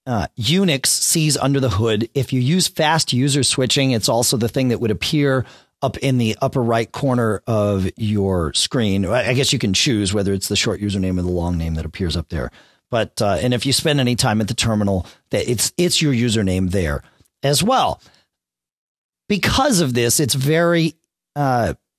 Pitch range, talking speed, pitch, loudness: 100-135 Hz, 195 wpm, 120 Hz, -18 LUFS